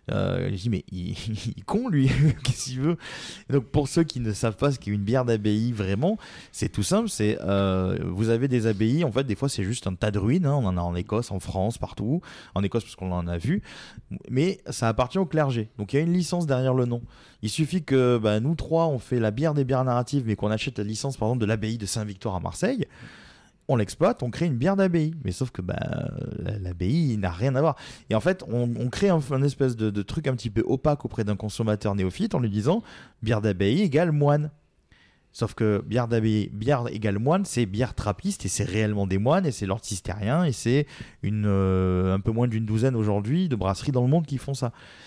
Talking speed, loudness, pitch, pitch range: 240 wpm, -26 LUFS, 120 Hz, 105-140 Hz